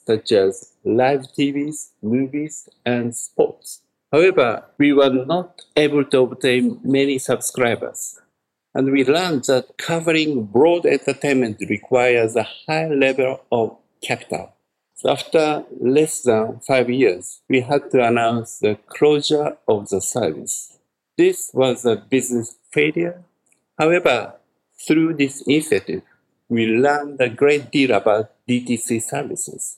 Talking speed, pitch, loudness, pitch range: 125 wpm, 135 Hz, -19 LUFS, 120-150 Hz